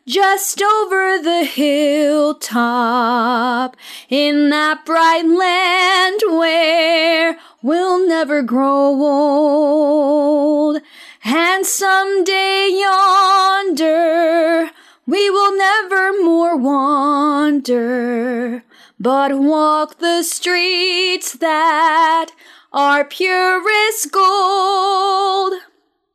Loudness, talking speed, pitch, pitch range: -14 LUFS, 65 wpm, 330 Hz, 290-375 Hz